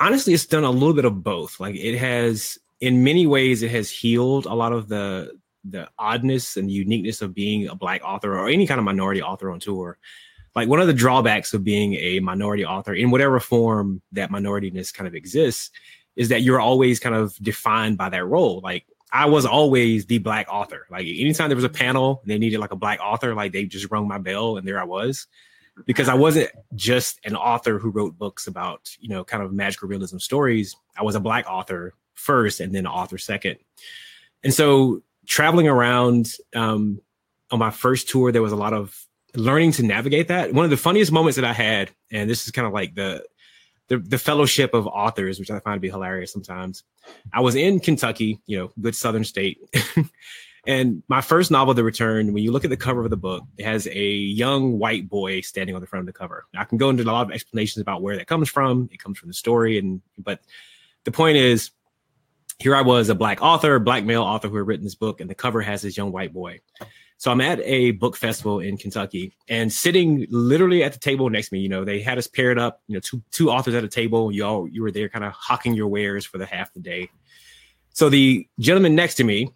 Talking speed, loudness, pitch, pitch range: 230 wpm, -21 LUFS, 115 Hz, 100-130 Hz